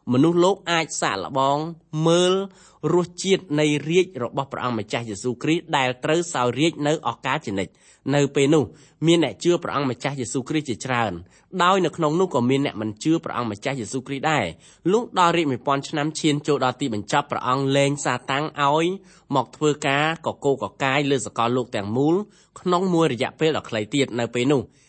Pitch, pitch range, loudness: 145 Hz, 125-165 Hz, -22 LUFS